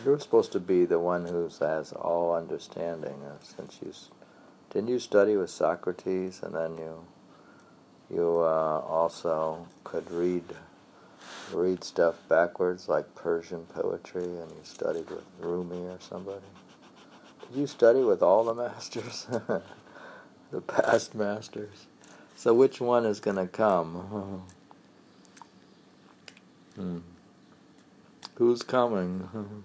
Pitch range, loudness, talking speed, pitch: 85-110 Hz, -29 LUFS, 125 wpm, 90 Hz